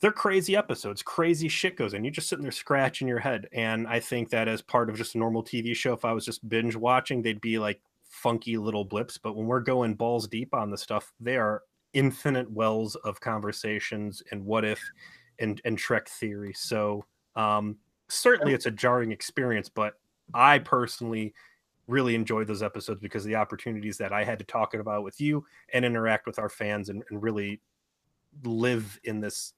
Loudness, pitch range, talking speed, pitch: -28 LUFS, 105-120 Hz, 195 wpm, 115 Hz